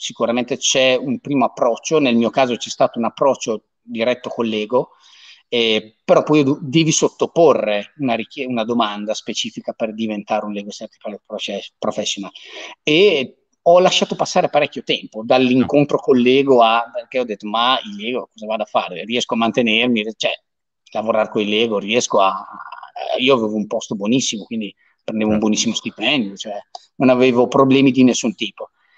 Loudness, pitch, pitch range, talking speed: -17 LUFS, 120 Hz, 110-135 Hz, 165 wpm